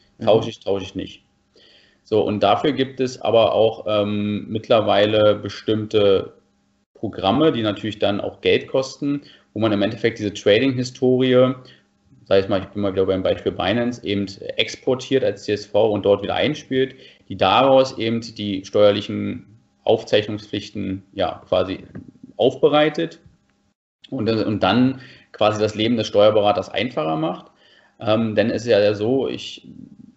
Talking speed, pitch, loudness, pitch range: 145 wpm, 110 Hz, -20 LUFS, 105-130 Hz